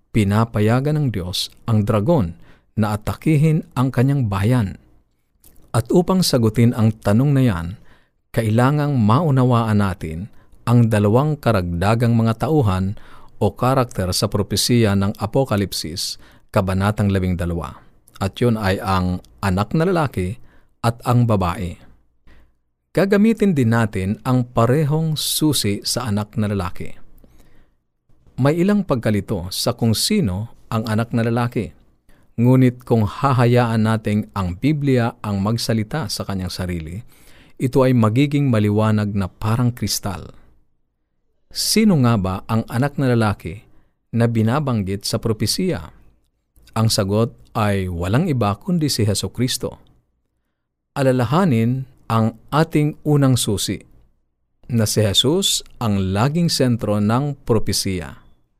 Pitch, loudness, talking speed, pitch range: 110 Hz, -19 LUFS, 115 wpm, 100-125 Hz